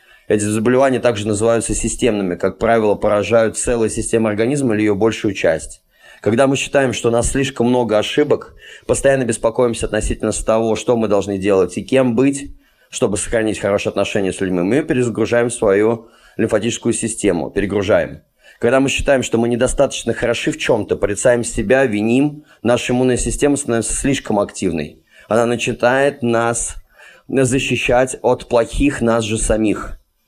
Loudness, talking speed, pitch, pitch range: -17 LUFS, 145 wpm, 115 Hz, 105-125 Hz